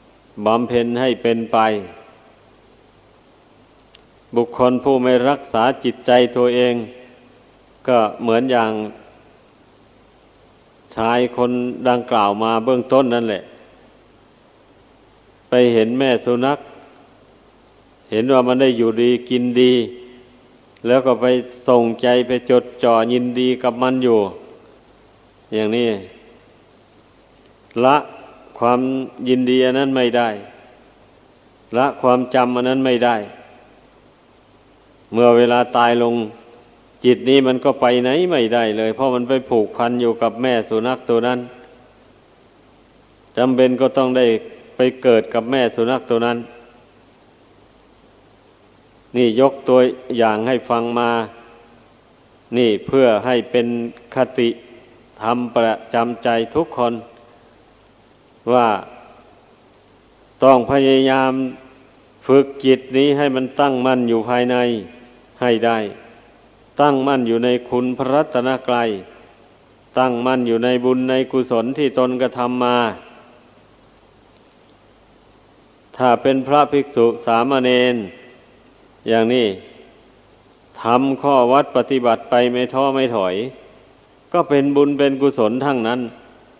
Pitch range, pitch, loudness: 115-130 Hz, 125 Hz, -17 LUFS